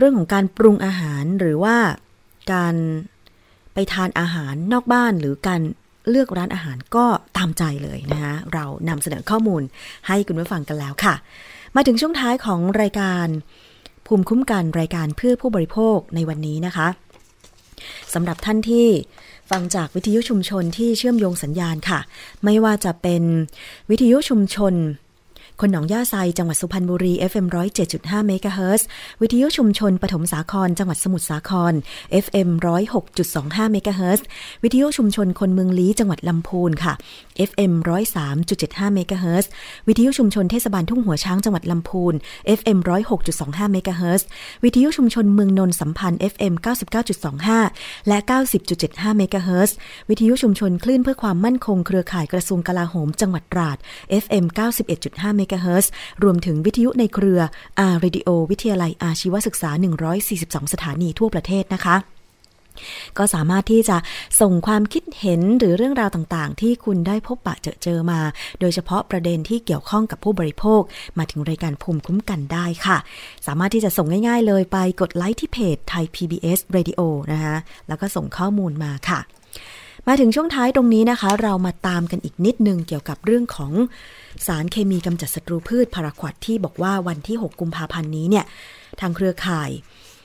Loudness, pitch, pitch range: -20 LUFS, 185 Hz, 170-210 Hz